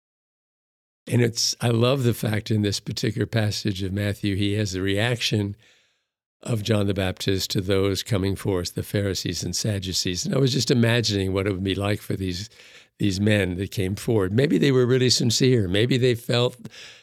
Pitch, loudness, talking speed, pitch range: 105 Hz, -23 LUFS, 185 wpm, 100-120 Hz